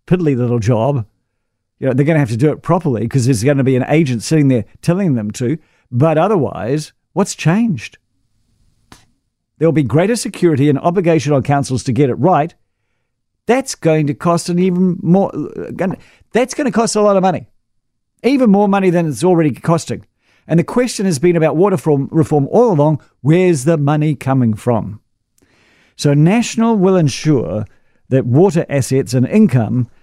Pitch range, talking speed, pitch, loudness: 120-175 Hz, 180 wpm, 145 Hz, -14 LUFS